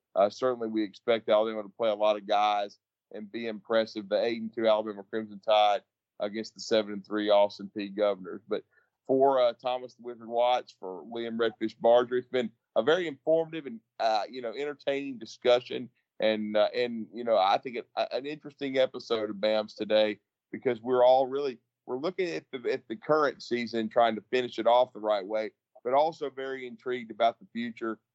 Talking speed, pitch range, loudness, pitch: 200 wpm, 105-125 Hz, -29 LUFS, 115 Hz